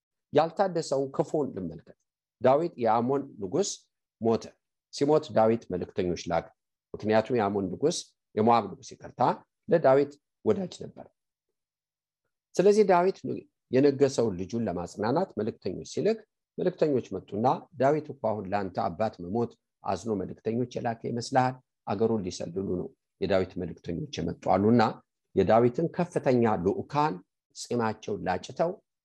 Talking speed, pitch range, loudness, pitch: 105 wpm, 110-155 Hz, -28 LUFS, 130 Hz